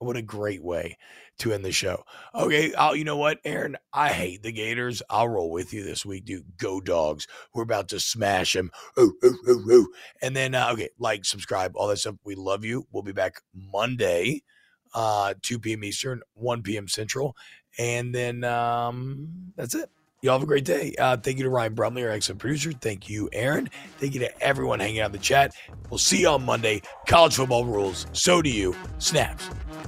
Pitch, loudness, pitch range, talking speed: 120 Hz, -25 LUFS, 105-140 Hz, 200 wpm